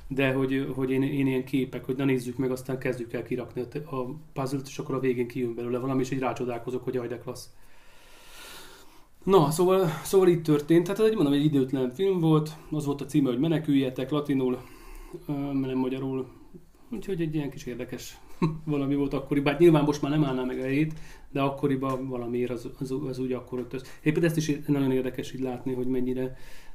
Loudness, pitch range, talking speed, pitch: -27 LUFS, 130-150 Hz, 200 wpm, 135 Hz